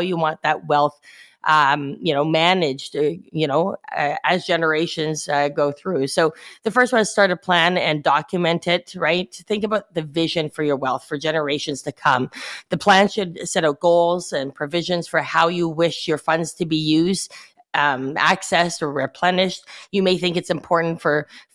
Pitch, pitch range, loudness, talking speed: 165 Hz, 150-180 Hz, -20 LUFS, 185 wpm